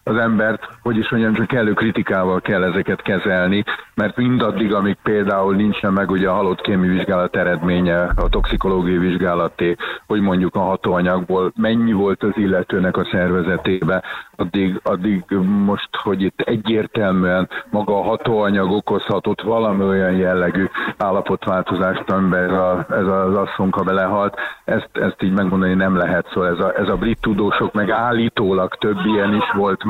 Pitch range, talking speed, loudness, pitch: 95-105 Hz, 150 wpm, -18 LUFS, 95 Hz